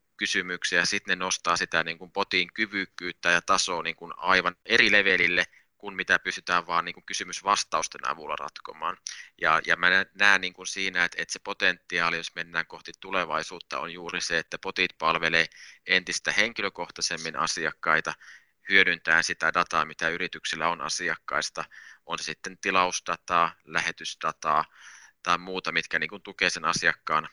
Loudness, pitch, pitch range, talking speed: -26 LUFS, 90 Hz, 85-95 Hz, 150 wpm